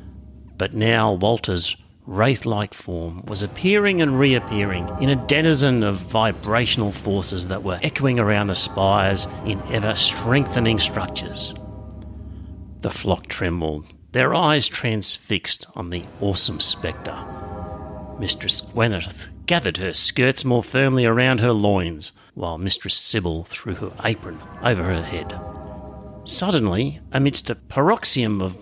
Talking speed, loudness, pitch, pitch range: 120 wpm, -20 LUFS, 100 Hz, 90-115 Hz